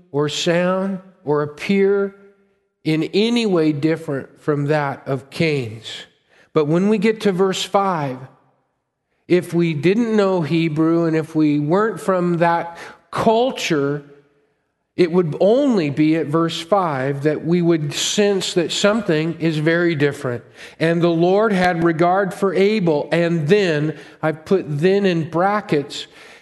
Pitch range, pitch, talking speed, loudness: 150-190 Hz, 170 Hz, 140 wpm, -18 LUFS